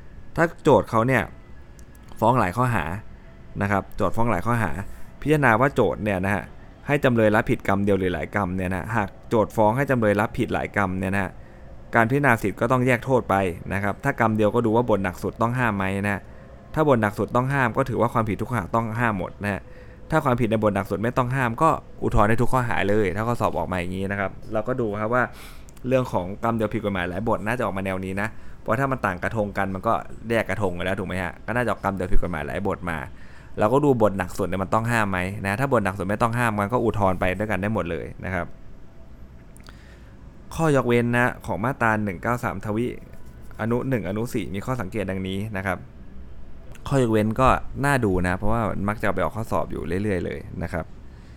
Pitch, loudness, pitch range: 105 Hz, -24 LUFS, 95-120 Hz